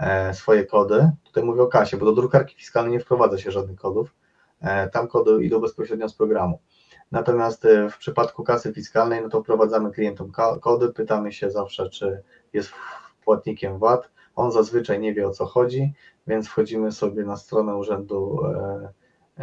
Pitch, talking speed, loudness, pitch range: 110 Hz, 155 wpm, -22 LUFS, 100-115 Hz